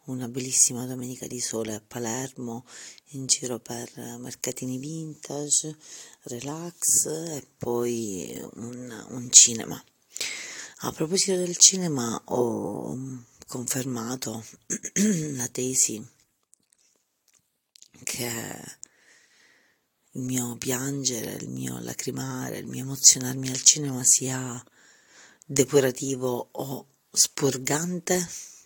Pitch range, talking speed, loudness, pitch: 120-140 Hz, 90 wpm, -24 LUFS, 130 Hz